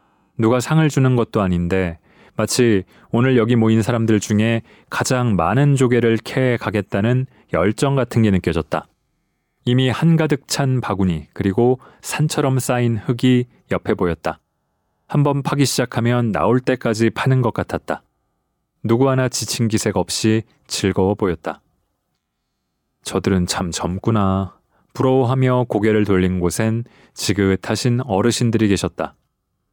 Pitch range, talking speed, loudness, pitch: 95-125 Hz, 270 characters per minute, -18 LUFS, 115 Hz